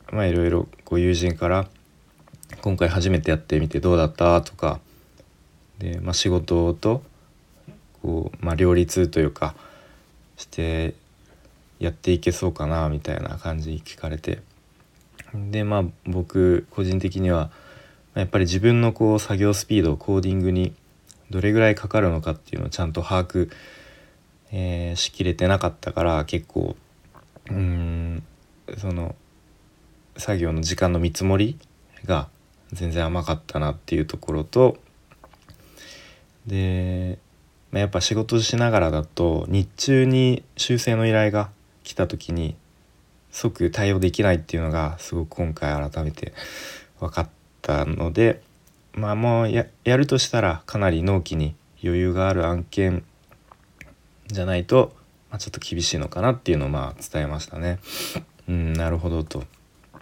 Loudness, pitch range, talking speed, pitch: -23 LUFS, 80-100 Hz, 275 characters per minute, 90 Hz